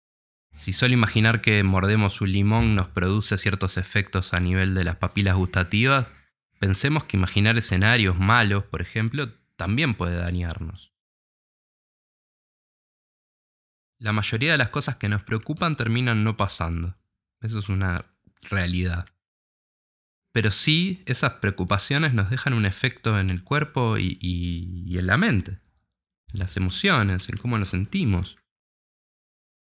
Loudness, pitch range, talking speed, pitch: -23 LUFS, 90-115 Hz, 135 wpm, 100 Hz